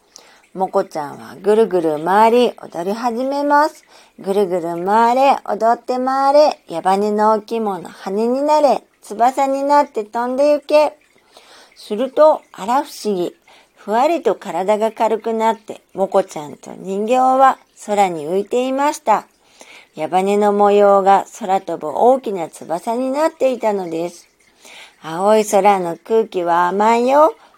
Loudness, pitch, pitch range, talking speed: -16 LUFS, 215 Hz, 195-260 Hz, 265 characters per minute